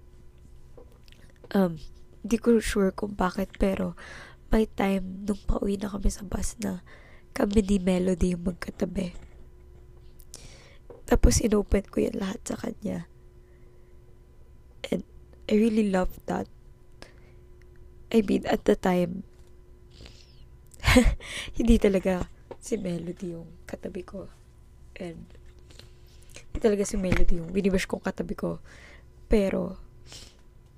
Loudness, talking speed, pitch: -27 LUFS, 110 wpm, 185 Hz